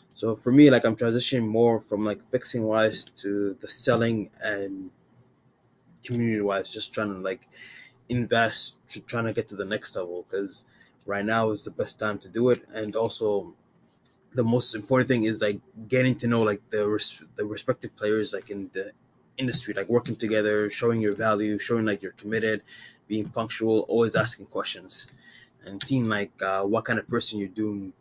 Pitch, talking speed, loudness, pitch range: 110 Hz, 185 wpm, -26 LUFS, 105-120 Hz